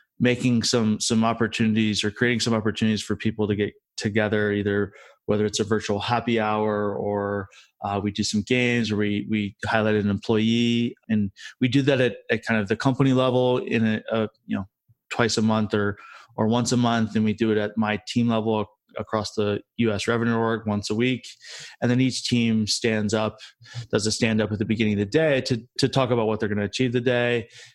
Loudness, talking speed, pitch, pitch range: -23 LUFS, 215 wpm, 110 Hz, 105-120 Hz